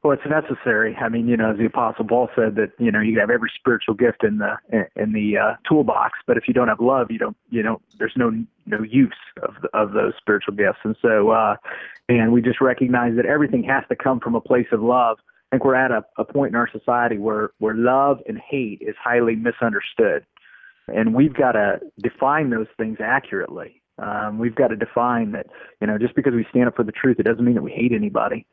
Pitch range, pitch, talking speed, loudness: 110-130 Hz, 120 Hz, 235 wpm, -20 LUFS